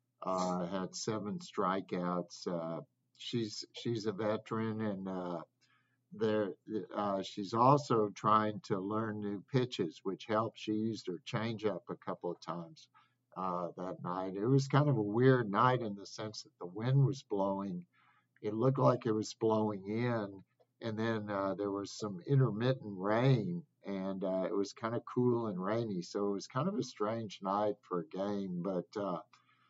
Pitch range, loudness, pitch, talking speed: 95-125 Hz, -35 LUFS, 110 Hz, 175 wpm